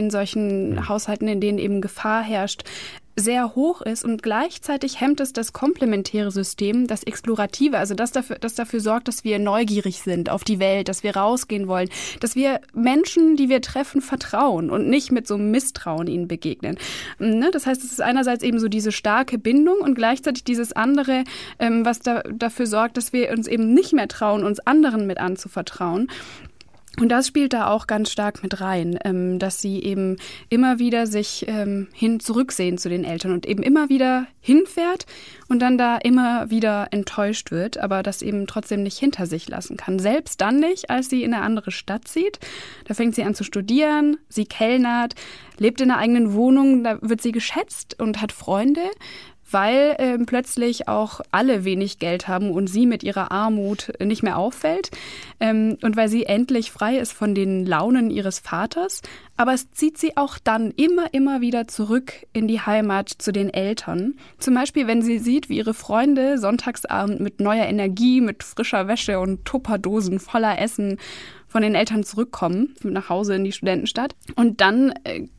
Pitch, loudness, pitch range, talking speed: 225 Hz, -21 LUFS, 205-255 Hz, 180 wpm